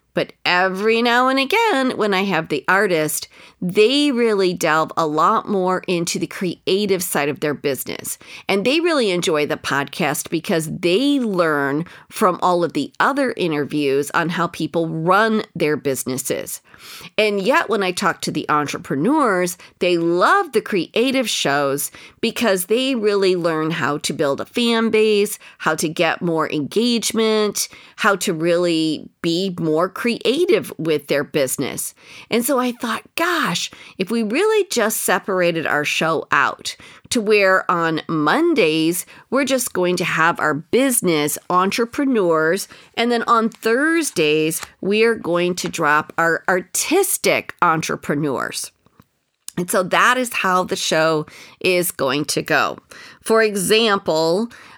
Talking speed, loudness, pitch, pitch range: 145 wpm, -18 LUFS, 185 Hz, 160-225 Hz